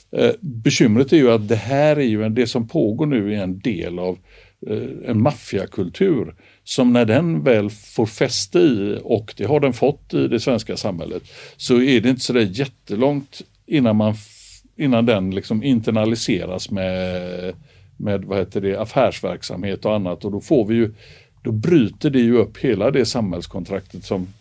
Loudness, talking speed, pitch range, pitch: -19 LUFS, 170 wpm, 100-125 Hz, 110 Hz